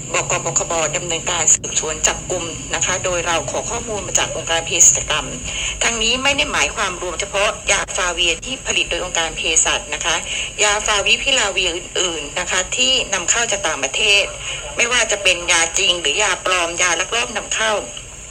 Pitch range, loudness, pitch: 165-205 Hz, -16 LUFS, 180 Hz